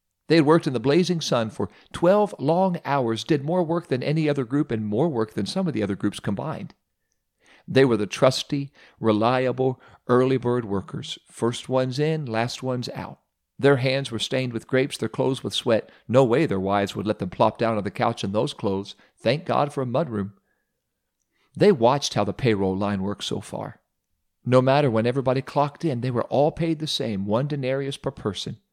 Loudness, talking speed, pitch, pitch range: -23 LUFS, 205 wpm, 130 Hz, 110-145 Hz